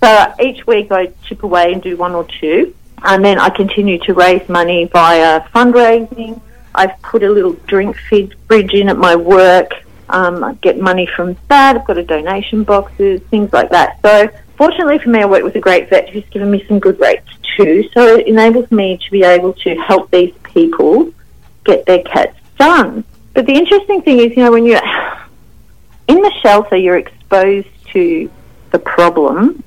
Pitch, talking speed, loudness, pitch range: 205 Hz, 190 wpm, -10 LUFS, 185-250 Hz